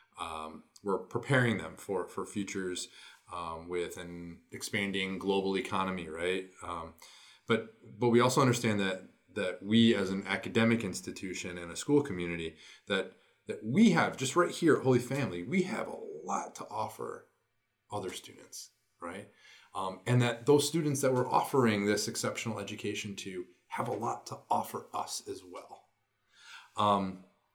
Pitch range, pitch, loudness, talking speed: 95-125 Hz, 105 Hz, -32 LUFS, 155 wpm